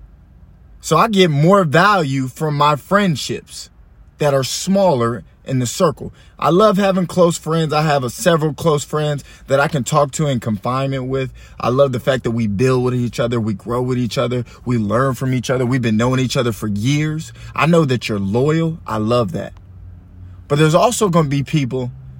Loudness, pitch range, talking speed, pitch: -17 LUFS, 120-155 Hz, 200 wpm, 130 Hz